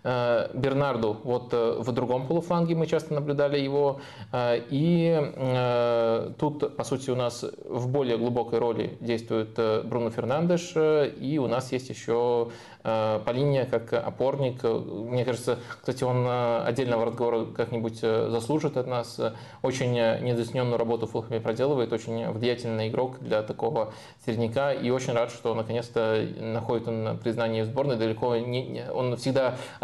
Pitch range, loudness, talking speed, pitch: 115-135 Hz, -27 LUFS, 130 wpm, 120 Hz